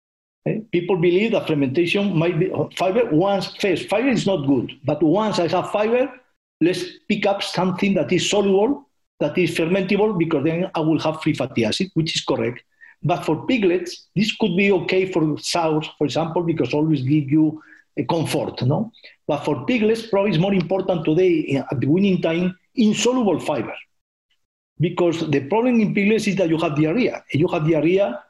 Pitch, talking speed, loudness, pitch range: 180 Hz, 180 wpm, -20 LUFS, 160-200 Hz